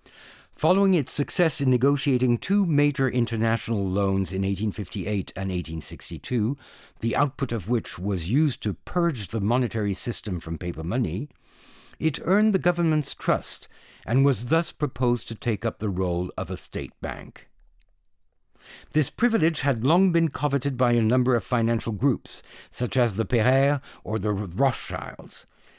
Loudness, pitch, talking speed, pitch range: -25 LUFS, 120 Hz, 150 wpm, 105-145 Hz